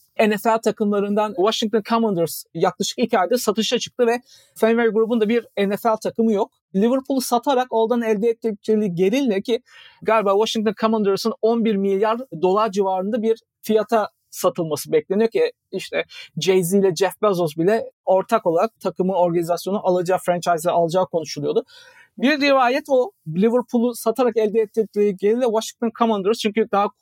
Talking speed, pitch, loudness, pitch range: 140 wpm, 220 Hz, -20 LUFS, 190-235 Hz